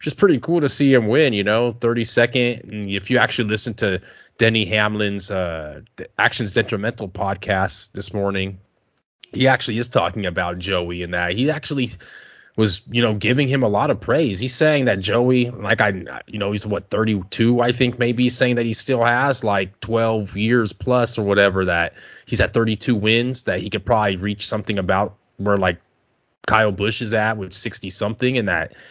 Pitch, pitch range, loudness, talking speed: 110 Hz, 100-120 Hz, -19 LUFS, 200 wpm